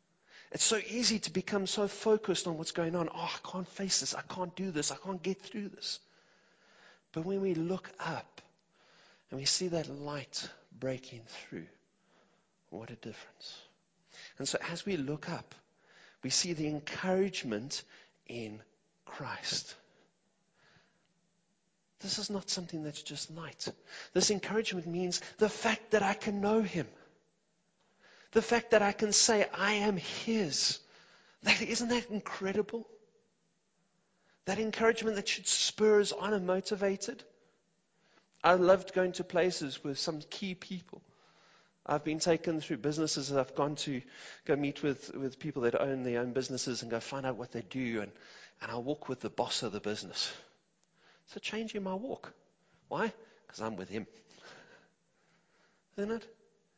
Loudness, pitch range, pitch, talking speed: -33 LUFS, 145-205 Hz, 185 Hz, 155 wpm